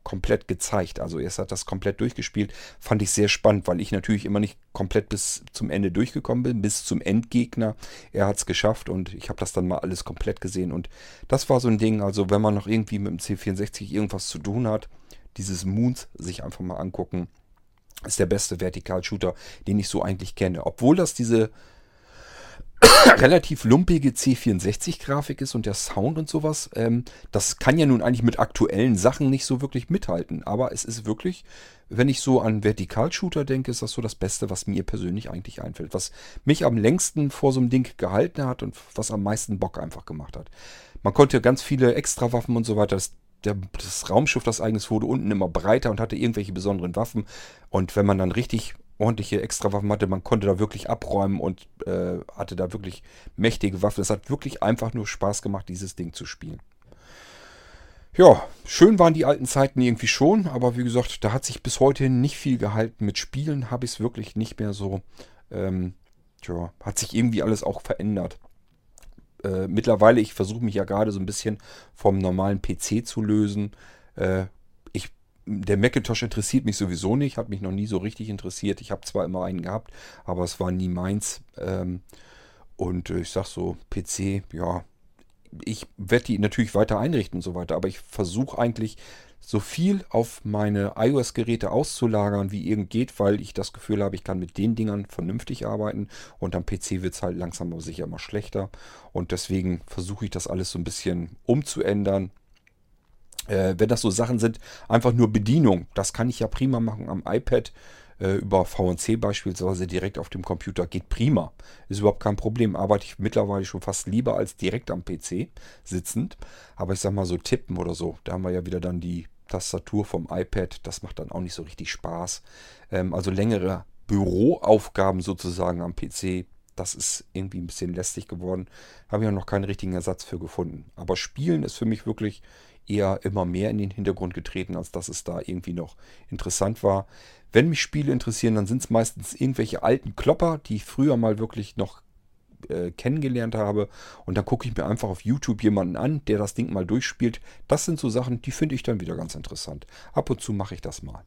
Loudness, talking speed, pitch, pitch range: -24 LUFS, 195 wpm, 105 Hz, 95-115 Hz